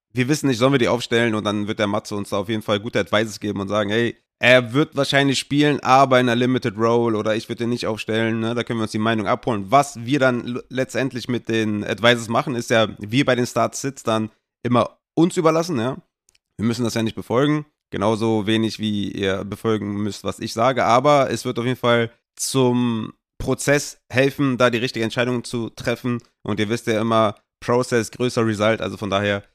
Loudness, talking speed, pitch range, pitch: -20 LUFS, 215 wpm, 110-125 Hz, 115 Hz